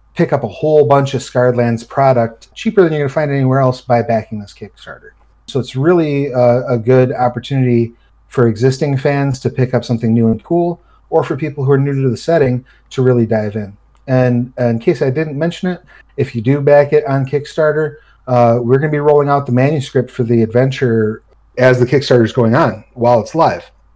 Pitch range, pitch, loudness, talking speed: 120-145 Hz, 130 Hz, -14 LUFS, 215 wpm